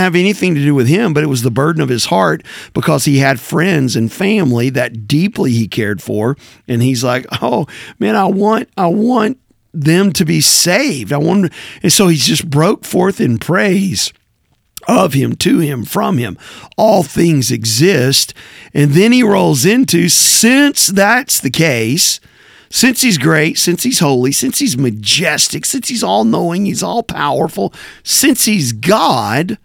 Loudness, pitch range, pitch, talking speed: -12 LUFS, 135-200 Hz, 170 Hz, 170 wpm